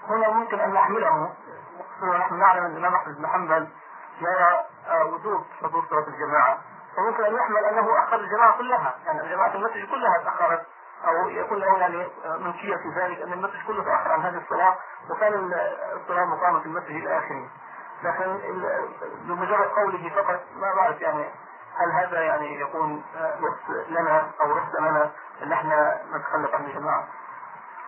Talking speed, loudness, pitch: 150 wpm, -24 LUFS, 200 Hz